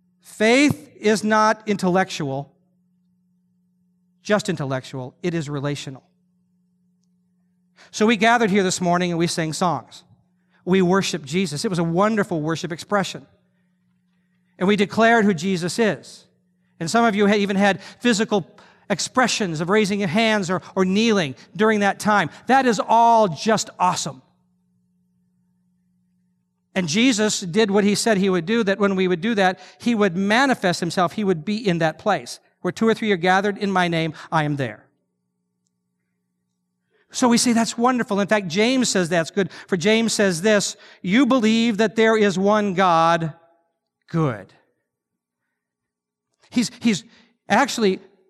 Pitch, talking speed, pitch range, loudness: 185 Hz, 150 wpm, 165-210 Hz, -20 LUFS